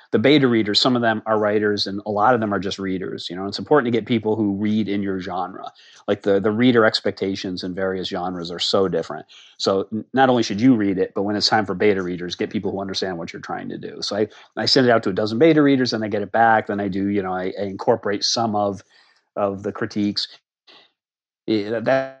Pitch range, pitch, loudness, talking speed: 100-115 Hz, 105 Hz, -20 LUFS, 255 wpm